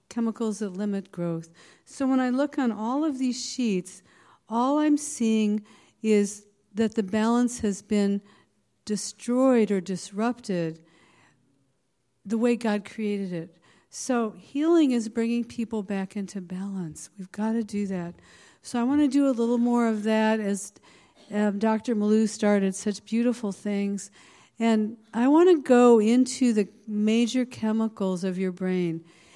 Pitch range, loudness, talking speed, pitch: 200-240 Hz, -25 LUFS, 150 wpm, 215 Hz